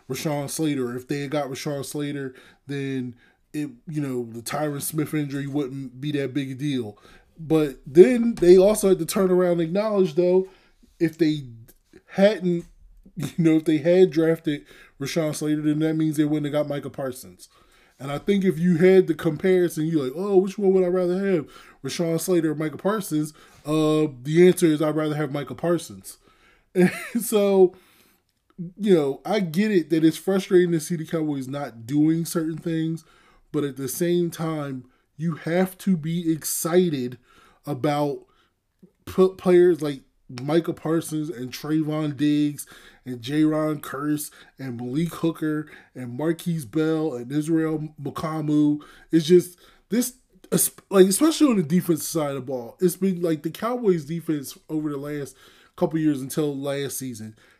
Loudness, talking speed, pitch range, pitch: -23 LUFS, 165 wpm, 145-180 Hz, 155 Hz